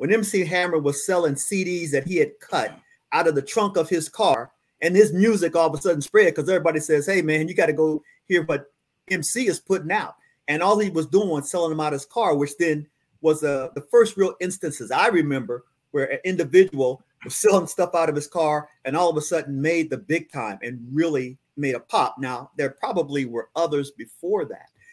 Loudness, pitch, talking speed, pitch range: -22 LUFS, 160 Hz, 225 wpm, 145-190 Hz